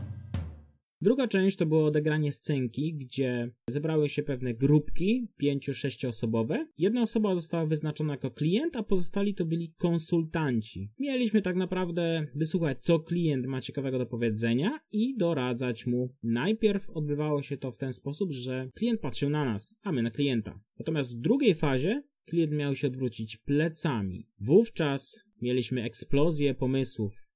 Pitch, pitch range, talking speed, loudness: 145 Hz, 125-175 Hz, 145 wpm, -30 LUFS